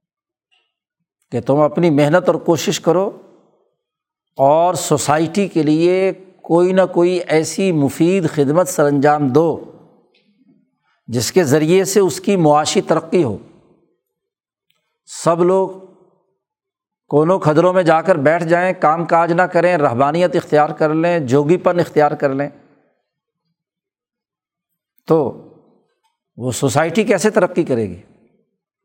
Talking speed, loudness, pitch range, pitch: 120 wpm, -15 LUFS, 150-190 Hz, 170 Hz